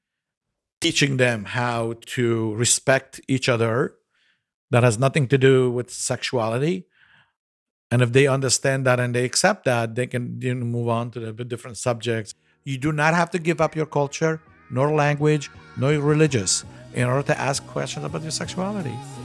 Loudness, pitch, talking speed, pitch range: -22 LUFS, 125 Hz, 170 wpm, 120-145 Hz